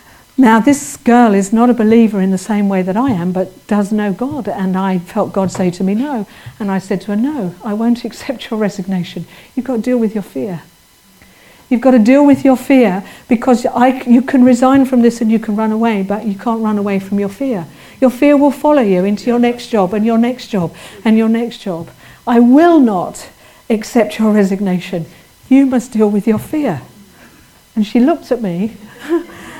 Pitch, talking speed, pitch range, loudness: 225 Hz, 215 wpm, 200-250 Hz, -13 LUFS